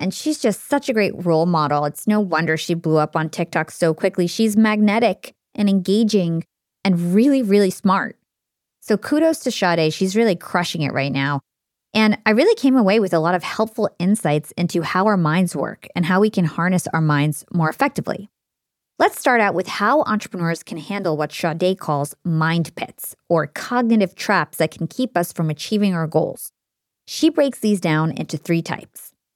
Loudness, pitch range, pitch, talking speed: -19 LUFS, 160-215 Hz, 180 Hz, 190 wpm